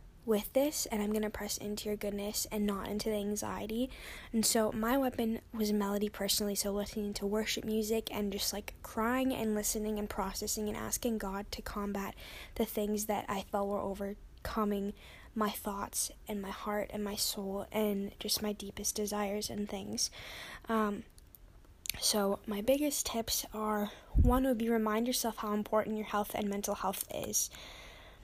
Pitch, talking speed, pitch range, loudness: 210 Hz, 170 wpm, 205-220 Hz, -35 LUFS